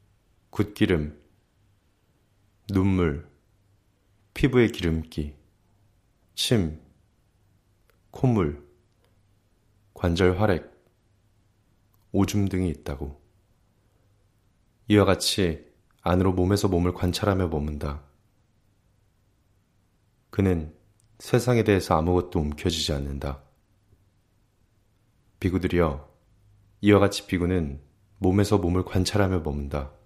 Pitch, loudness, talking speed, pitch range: 100 Hz, -25 LUFS, 175 characters per minute, 90-105 Hz